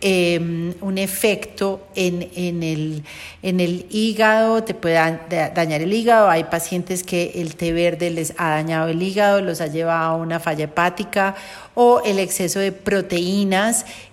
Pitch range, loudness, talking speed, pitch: 165-195 Hz, -19 LUFS, 165 wpm, 180 Hz